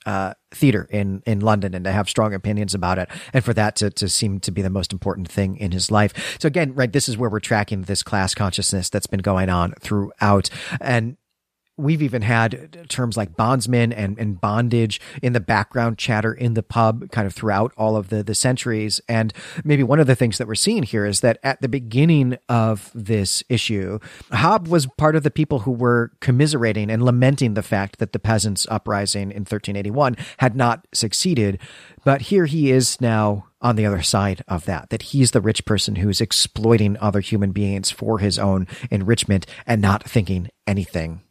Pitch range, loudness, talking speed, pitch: 100-125 Hz, -20 LUFS, 200 wpm, 110 Hz